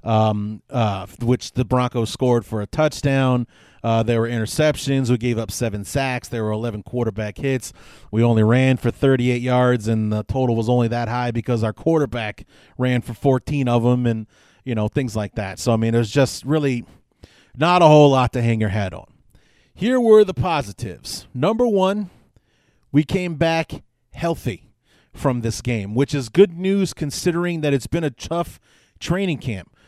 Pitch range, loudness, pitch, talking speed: 115-145 Hz, -20 LUFS, 125 Hz, 180 wpm